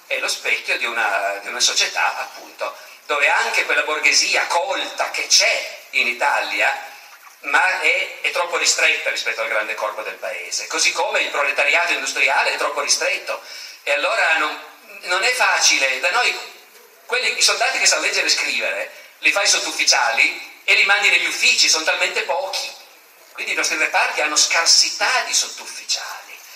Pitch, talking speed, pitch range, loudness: 175 Hz, 165 wpm, 150-245 Hz, -17 LUFS